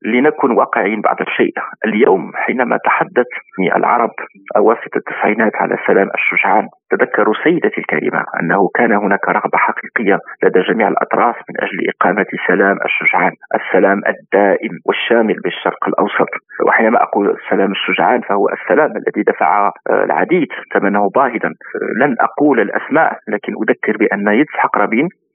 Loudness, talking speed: -14 LUFS, 125 wpm